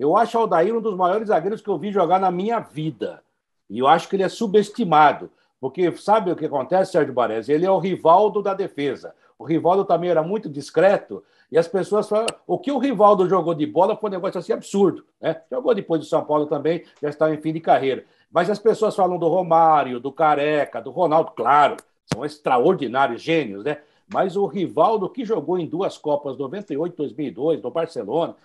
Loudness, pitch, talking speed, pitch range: -21 LUFS, 170 Hz, 210 wpm, 150-200 Hz